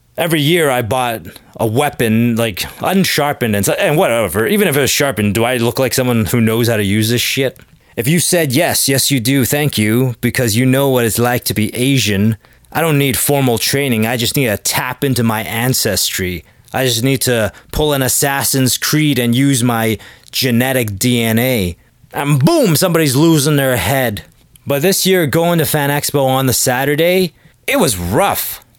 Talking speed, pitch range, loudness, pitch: 190 wpm, 115-145 Hz, -14 LUFS, 130 Hz